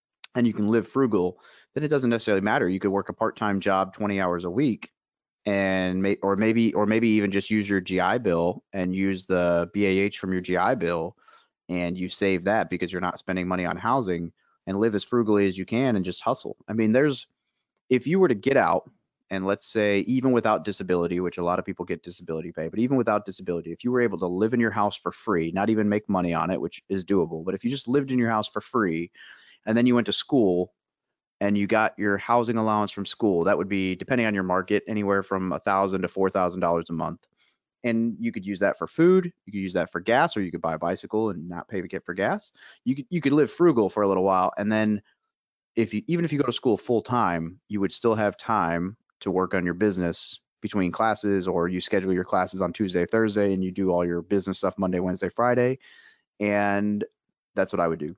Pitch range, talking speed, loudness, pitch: 90-110 Hz, 240 wpm, -25 LUFS, 100 Hz